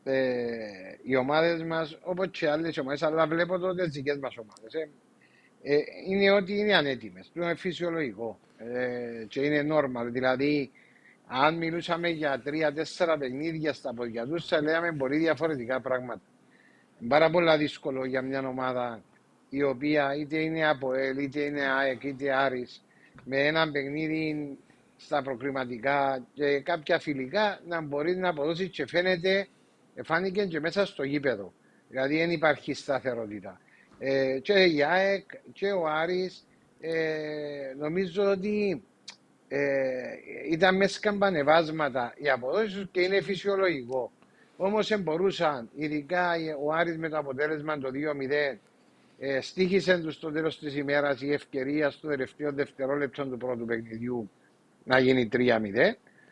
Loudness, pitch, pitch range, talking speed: -28 LUFS, 150 Hz, 135-170 Hz, 135 wpm